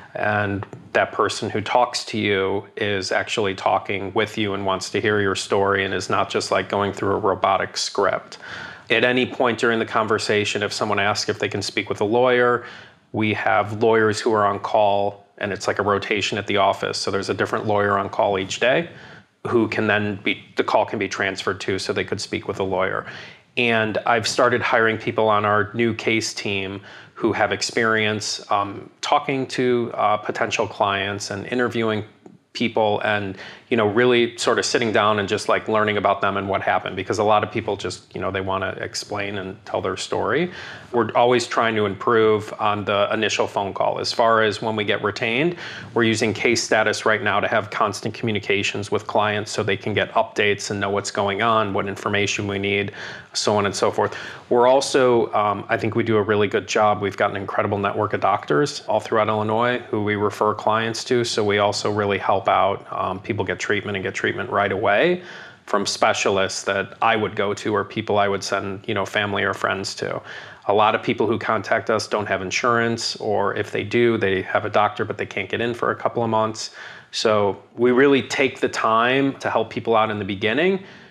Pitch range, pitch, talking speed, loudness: 100-115 Hz, 105 Hz, 215 wpm, -21 LUFS